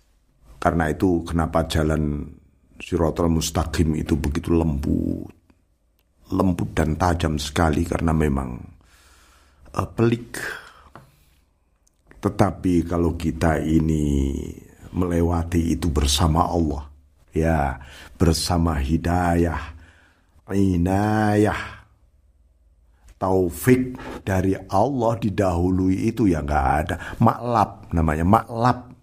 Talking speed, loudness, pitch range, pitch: 80 wpm, -22 LUFS, 75-95 Hz, 85 Hz